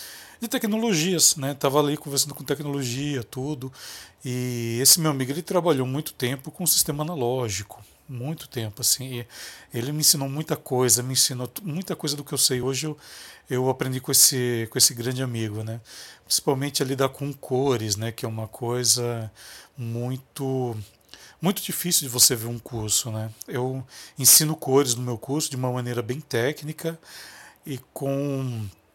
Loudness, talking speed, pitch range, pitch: -23 LUFS, 165 wpm, 120-150 Hz, 130 Hz